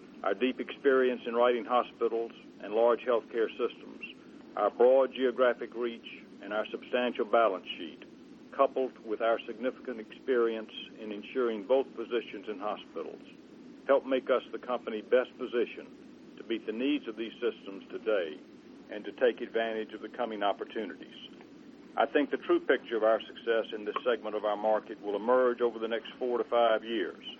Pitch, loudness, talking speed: 125 Hz, -31 LUFS, 165 wpm